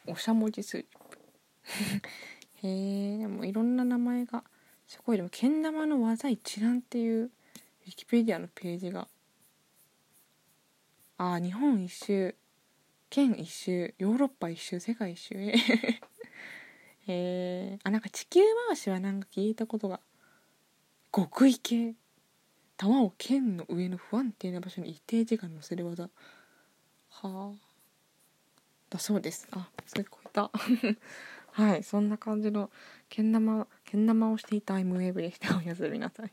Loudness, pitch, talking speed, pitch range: -31 LUFS, 215 Hz, 260 characters per minute, 190-235 Hz